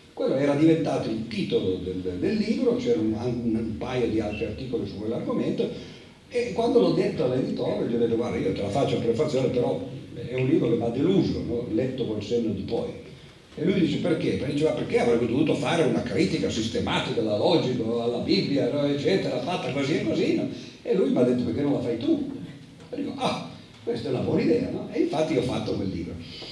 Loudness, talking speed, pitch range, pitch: -25 LUFS, 220 wpm, 115-155 Hz, 125 Hz